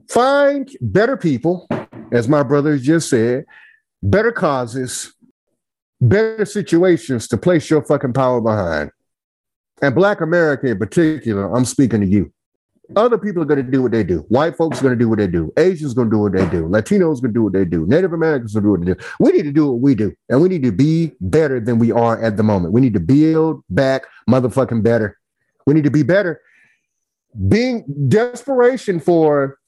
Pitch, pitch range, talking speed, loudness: 140 Hz, 115-170 Hz, 210 wpm, -16 LUFS